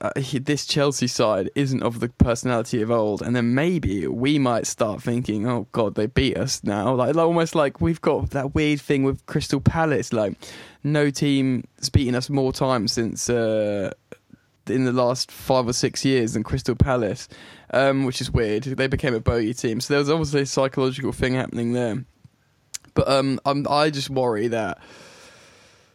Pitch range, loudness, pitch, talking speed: 120-140 Hz, -22 LUFS, 130 Hz, 185 wpm